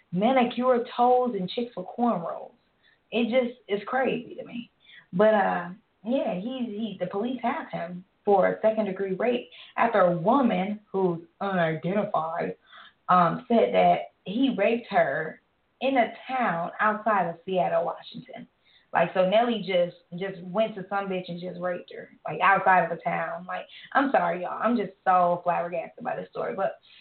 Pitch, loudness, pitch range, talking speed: 205 Hz, -26 LUFS, 180-235 Hz, 165 wpm